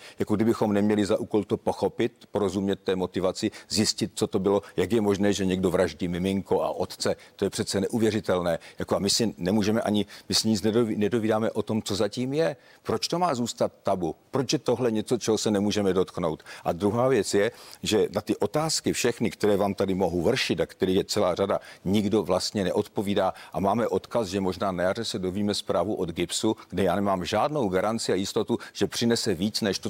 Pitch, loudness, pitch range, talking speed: 105 Hz, -26 LUFS, 95-110 Hz, 205 wpm